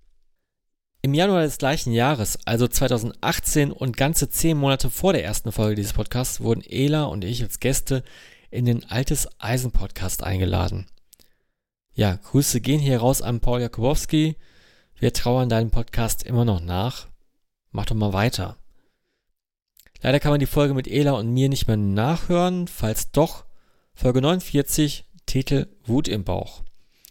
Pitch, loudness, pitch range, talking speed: 125 Hz, -23 LUFS, 105-140 Hz, 150 wpm